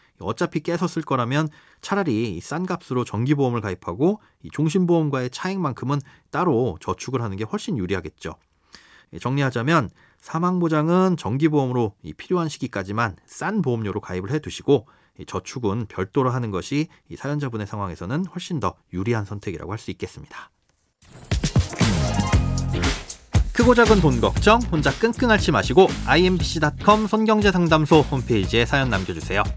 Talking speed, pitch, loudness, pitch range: 340 characters per minute, 135 Hz, -22 LUFS, 105-170 Hz